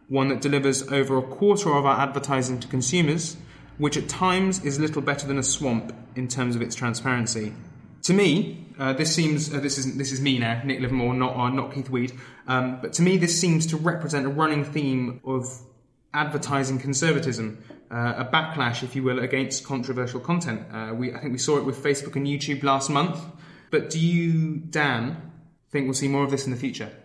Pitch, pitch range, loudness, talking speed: 135 Hz, 125-150 Hz, -25 LUFS, 205 wpm